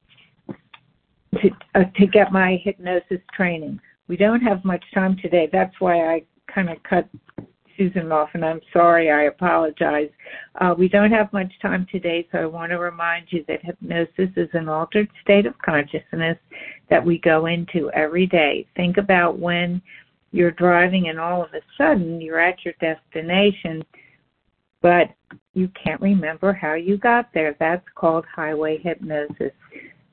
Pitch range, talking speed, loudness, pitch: 165-190 Hz, 155 wpm, -20 LUFS, 175 Hz